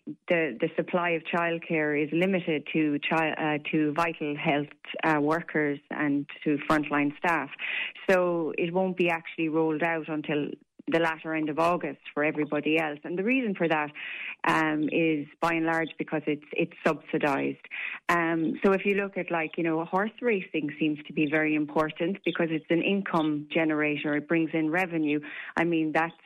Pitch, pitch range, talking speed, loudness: 160 Hz, 150-170 Hz, 175 wpm, -28 LUFS